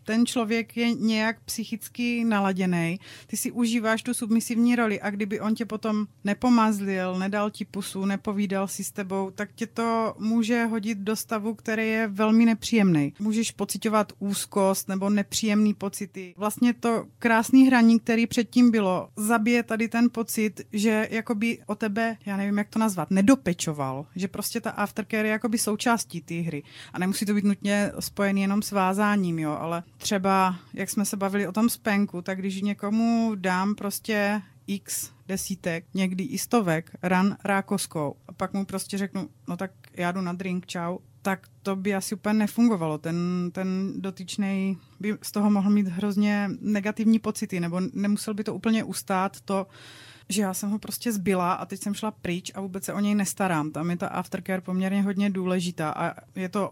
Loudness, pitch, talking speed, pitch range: -26 LUFS, 205 Hz, 175 wpm, 190-220 Hz